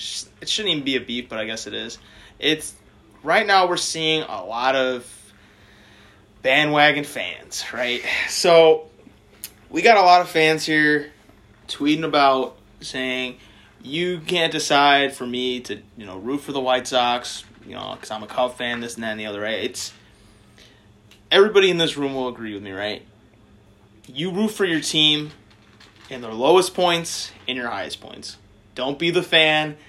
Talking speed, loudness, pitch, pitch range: 175 wpm, -20 LUFS, 125 Hz, 105-155 Hz